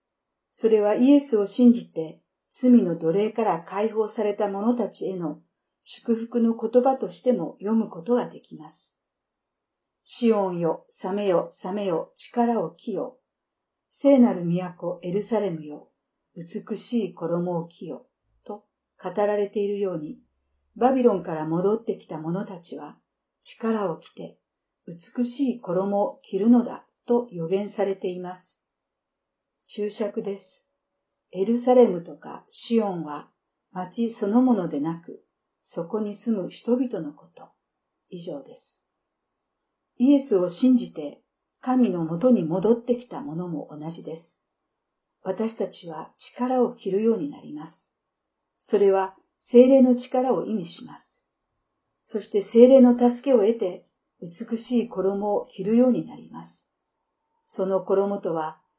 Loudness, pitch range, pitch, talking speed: -24 LUFS, 180-240 Hz, 210 Hz, 245 characters per minute